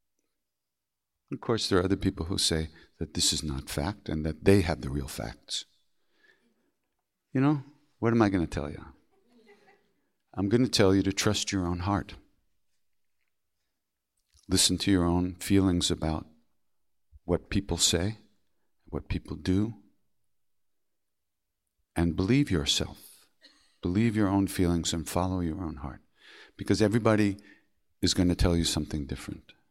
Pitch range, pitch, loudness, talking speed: 75-100 Hz, 90 Hz, -28 LUFS, 145 wpm